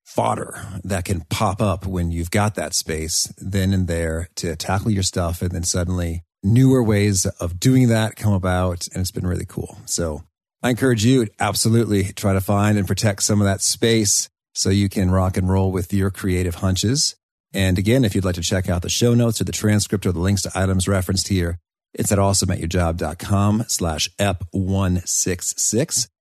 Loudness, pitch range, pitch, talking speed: -20 LUFS, 90-105 Hz, 95 Hz, 190 wpm